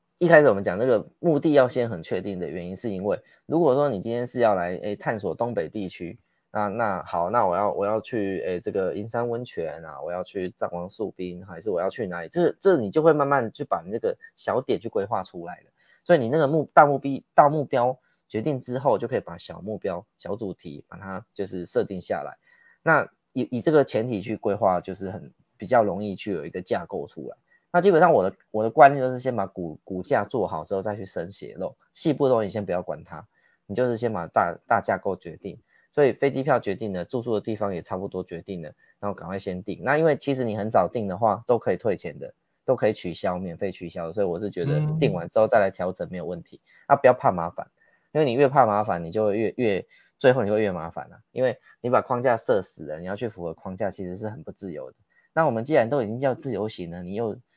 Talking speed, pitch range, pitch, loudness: 345 characters per minute, 95-130 Hz, 105 Hz, -25 LUFS